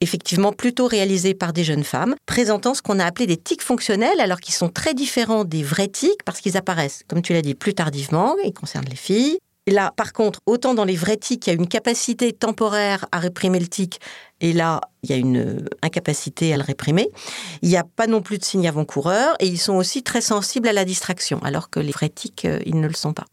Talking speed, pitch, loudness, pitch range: 240 wpm, 190 Hz, -21 LUFS, 165-220 Hz